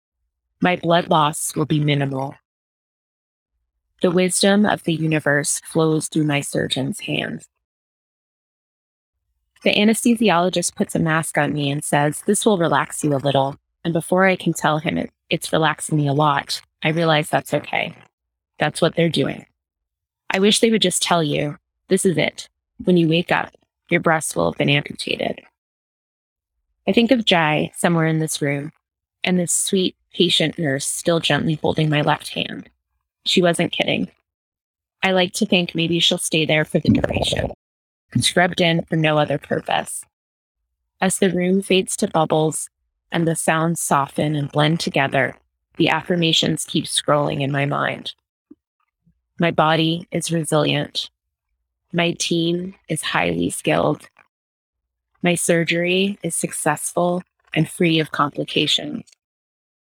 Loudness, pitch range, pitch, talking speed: -19 LUFS, 135-175 Hz, 160 Hz, 145 wpm